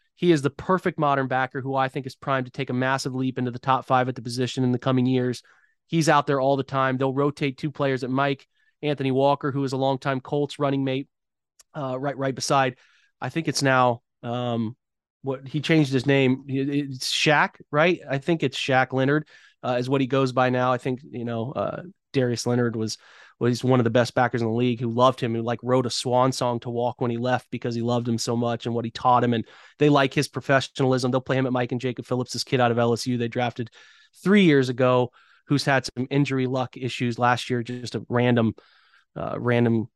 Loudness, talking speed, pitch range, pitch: -24 LUFS, 235 wpm, 125-140 Hz, 130 Hz